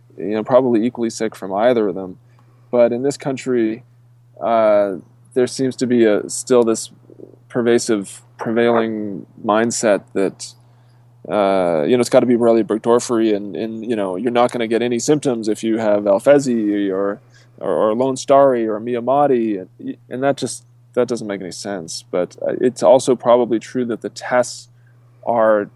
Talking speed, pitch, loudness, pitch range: 170 wpm, 120 Hz, -18 LUFS, 110-125 Hz